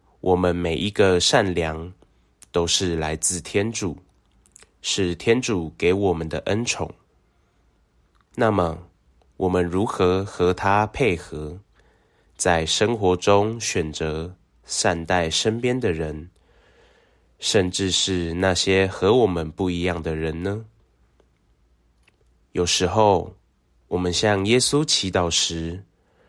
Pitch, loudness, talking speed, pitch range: 90 Hz, -22 LUFS, 160 characters per minute, 80-100 Hz